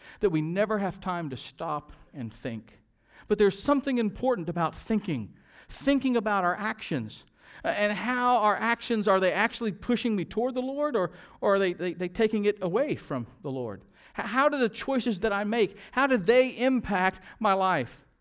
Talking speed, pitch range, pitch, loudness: 185 wpm, 170-235 Hz, 205 Hz, -27 LUFS